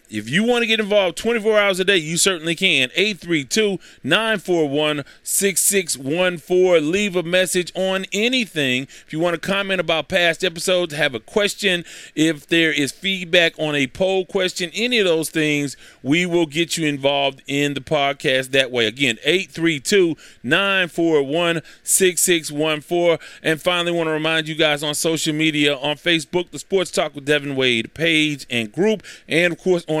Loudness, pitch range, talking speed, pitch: -19 LUFS, 150-185 Hz, 165 wpm, 170 Hz